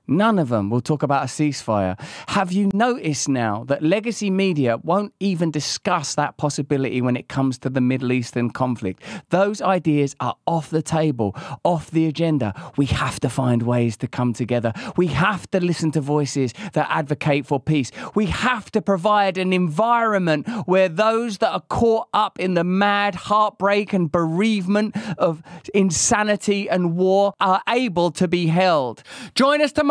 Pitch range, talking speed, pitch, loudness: 140-205 Hz, 170 wpm, 175 Hz, -20 LUFS